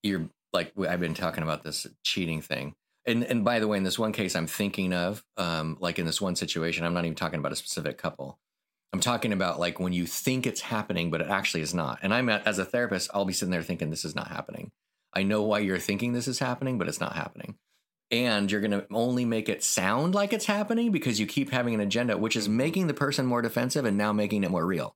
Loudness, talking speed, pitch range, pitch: -28 LUFS, 255 wpm, 85-120 Hz, 105 Hz